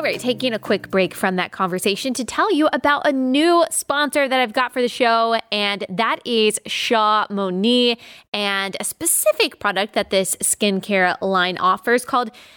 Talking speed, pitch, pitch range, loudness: 175 wpm, 230 Hz, 195-260 Hz, -19 LUFS